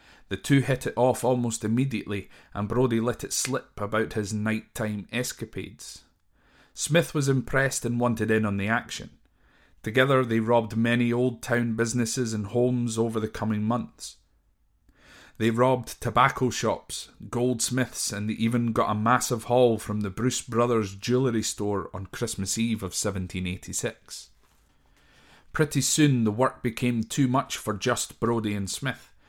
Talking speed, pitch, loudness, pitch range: 150 wpm, 115 Hz, -26 LUFS, 105-125 Hz